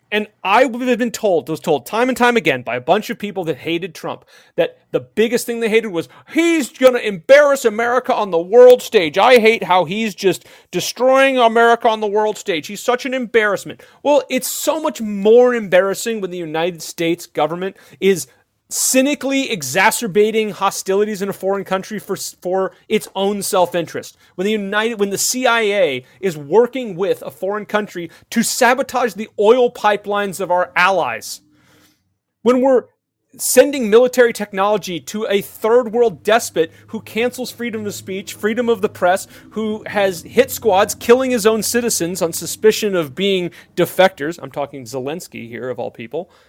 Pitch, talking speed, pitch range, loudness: 210 Hz, 170 wpm, 185-240 Hz, -16 LUFS